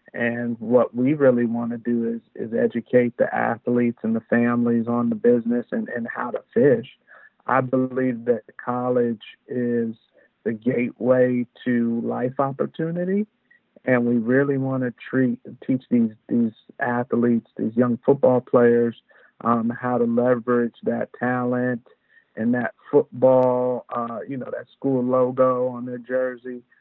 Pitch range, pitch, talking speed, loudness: 120-130 Hz, 125 Hz, 145 wpm, -22 LUFS